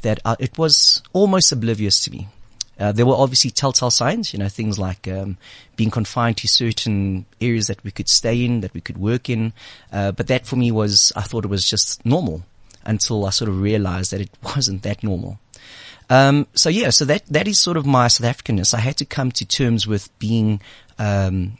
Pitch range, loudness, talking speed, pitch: 100-125 Hz, -18 LUFS, 210 wpm, 115 Hz